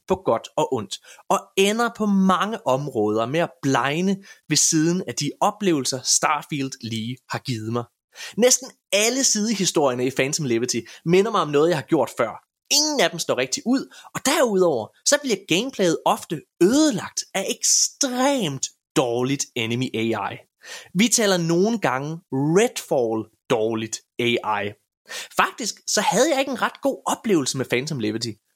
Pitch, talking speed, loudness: 165 Hz, 155 wpm, -21 LUFS